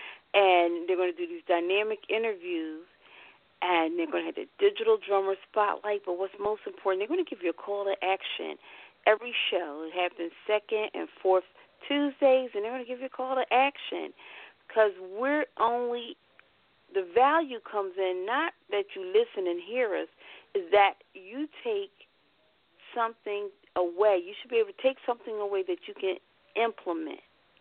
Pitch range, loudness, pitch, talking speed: 190-290 Hz, -29 LUFS, 215 Hz, 175 wpm